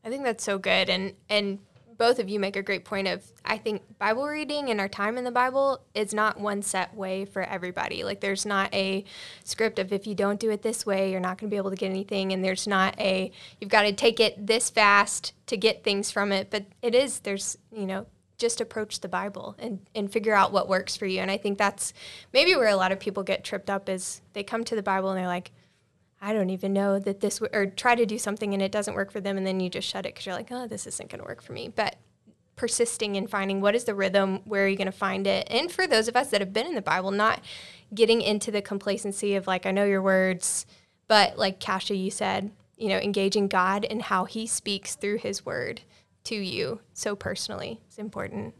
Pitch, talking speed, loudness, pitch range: 200 Hz, 250 wpm, -26 LUFS, 195-220 Hz